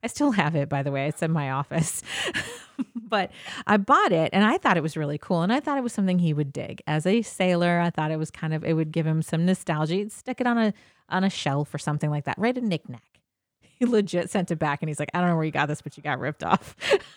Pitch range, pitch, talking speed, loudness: 150-200 Hz, 165 Hz, 285 wpm, -25 LUFS